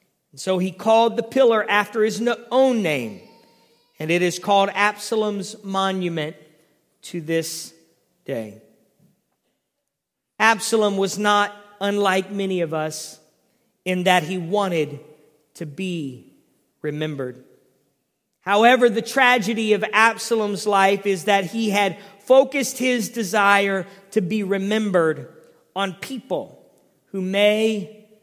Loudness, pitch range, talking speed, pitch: -20 LUFS, 180-220 Hz, 110 wpm, 200 Hz